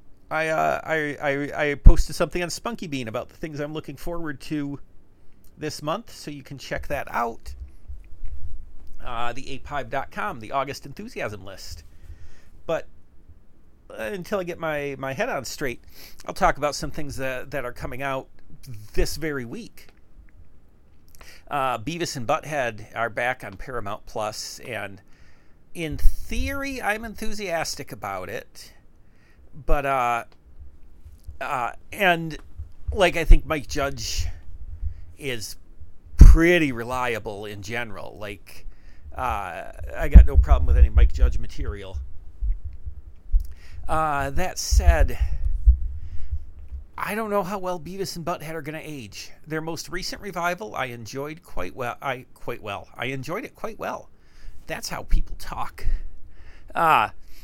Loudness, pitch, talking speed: -26 LUFS, 110 Hz, 140 wpm